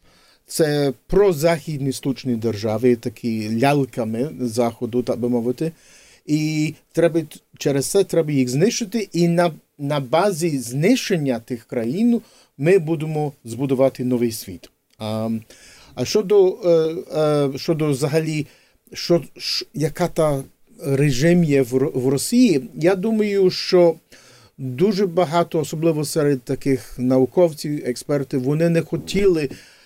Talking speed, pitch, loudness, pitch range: 115 wpm, 150 Hz, -20 LUFS, 130-170 Hz